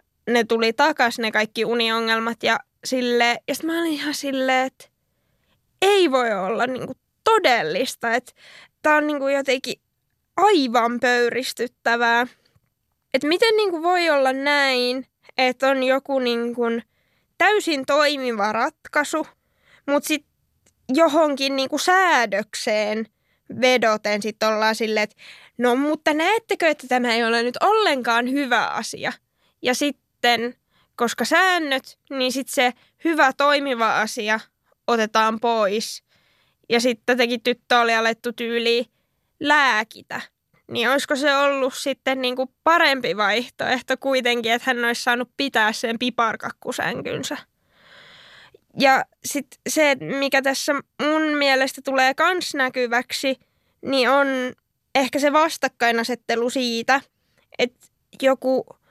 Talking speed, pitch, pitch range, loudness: 115 wpm, 260 Hz, 235-285 Hz, -20 LUFS